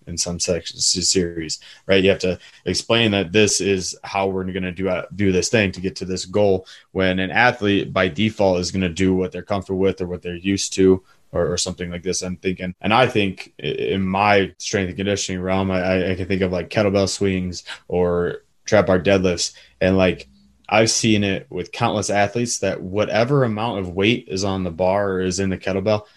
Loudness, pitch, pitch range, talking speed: -20 LUFS, 95 Hz, 90-100 Hz, 215 wpm